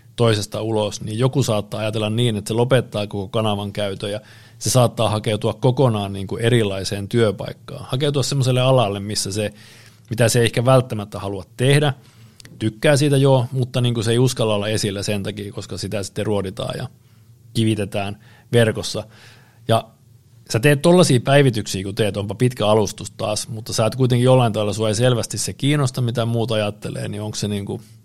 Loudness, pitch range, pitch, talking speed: -20 LUFS, 105-125 Hz, 115 Hz, 180 wpm